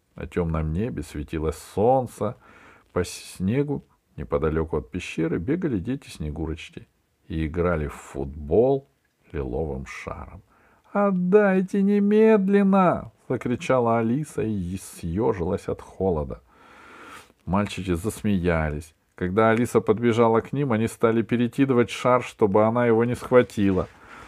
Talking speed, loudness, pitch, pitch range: 105 wpm, -24 LUFS, 110 Hz, 90-130 Hz